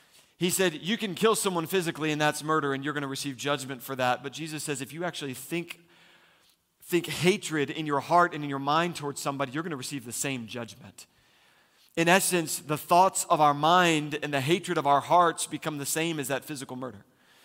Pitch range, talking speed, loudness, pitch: 140-170 Hz, 215 wpm, -27 LUFS, 150 Hz